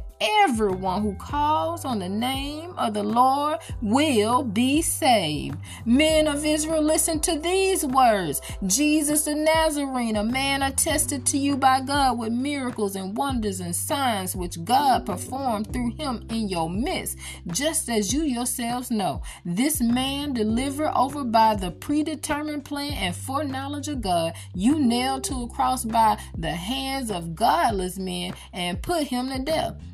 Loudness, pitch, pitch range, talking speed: -24 LUFS, 255 Hz, 210-295 Hz, 150 wpm